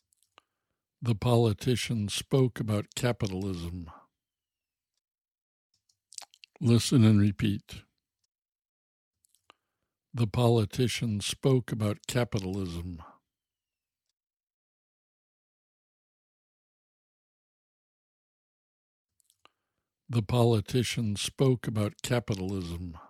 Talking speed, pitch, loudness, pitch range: 45 wpm, 110 Hz, -28 LUFS, 95-120 Hz